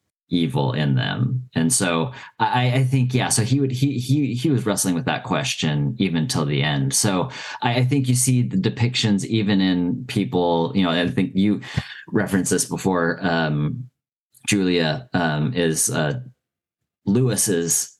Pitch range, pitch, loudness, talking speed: 85-125 Hz, 100 Hz, -21 LUFS, 165 wpm